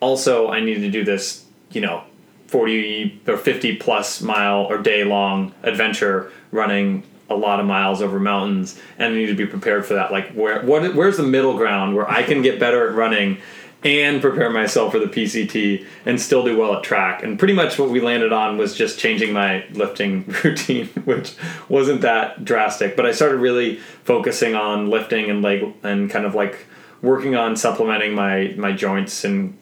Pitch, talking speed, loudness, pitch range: 105 Hz, 195 wpm, -19 LUFS, 100-115 Hz